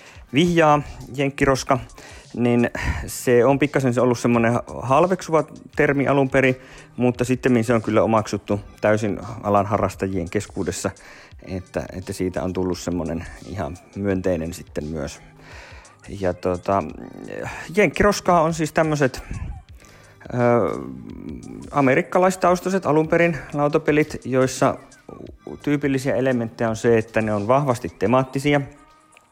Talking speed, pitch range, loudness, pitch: 105 wpm, 100-145 Hz, -21 LUFS, 120 Hz